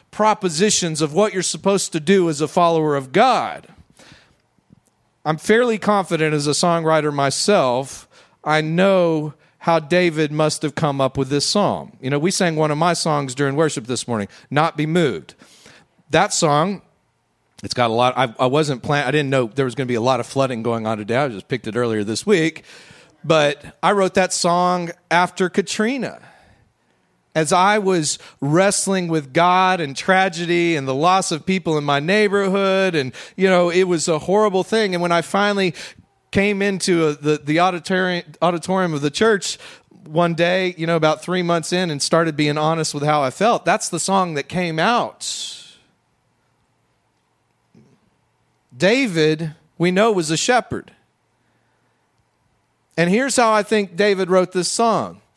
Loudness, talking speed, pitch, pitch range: -18 LUFS, 170 wpm, 170 Hz, 150-185 Hz